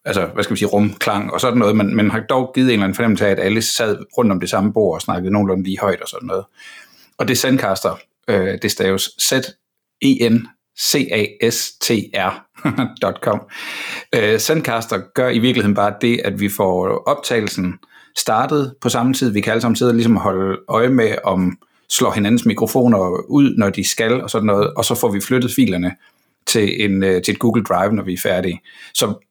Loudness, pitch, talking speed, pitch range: -17 LUFS, 110 Hz, 195 wpm, 100-125 Hz